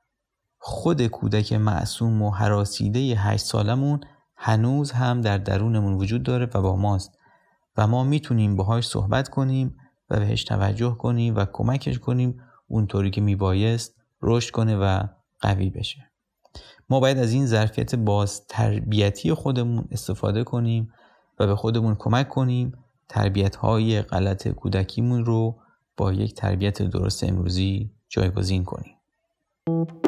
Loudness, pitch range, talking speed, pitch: -24 LUFS, 100-125 Hz, 130 wpm, 110 Hz